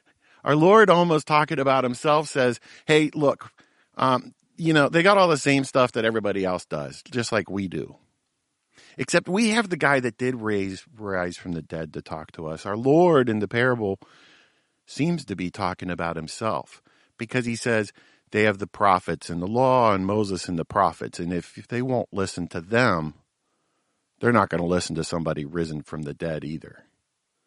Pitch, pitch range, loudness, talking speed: 110 Hz, 90-140 Hz, -23 LUFS, 190 wpm